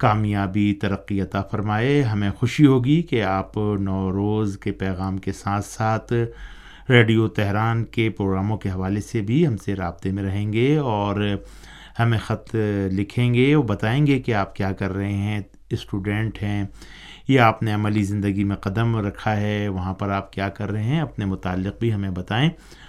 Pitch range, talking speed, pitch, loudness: 100-115 Hz, 175 wpm, 105 Hz, -22 LUFS